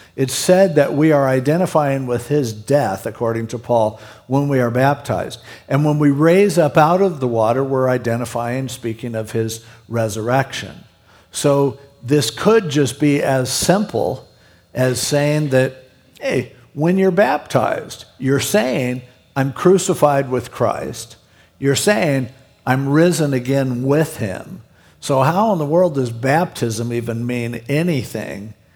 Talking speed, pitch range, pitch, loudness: 140 wpm, 120-150 Hz, 135 Hz, -17 LUFS